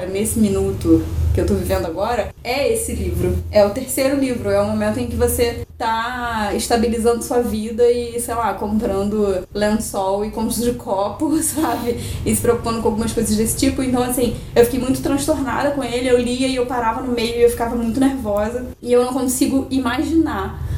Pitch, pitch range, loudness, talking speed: 235 Hz, 210-255 Hz, -19 LUFS, 195 wpm